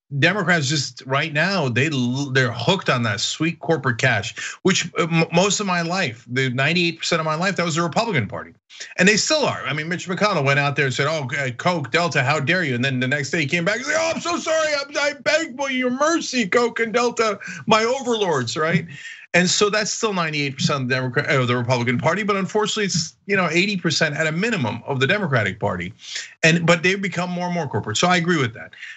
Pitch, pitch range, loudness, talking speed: 170 Hz, 140-200 Hz, -20 LUFS, 230 wpm